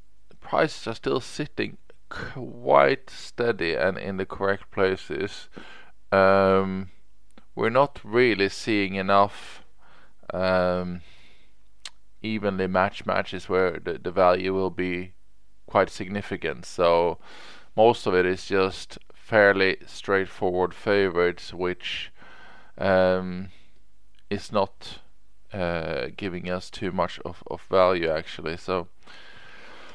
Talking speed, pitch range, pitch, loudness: 105 wpm, 90-100 Hz, 95 Hz, -25 LUFS